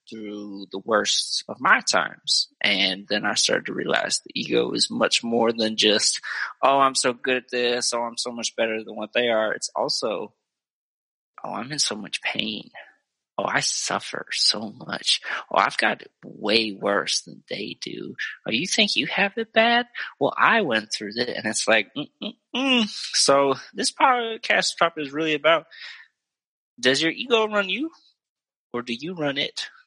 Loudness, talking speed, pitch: -22 LUFS, 175 wpm, 135 Hz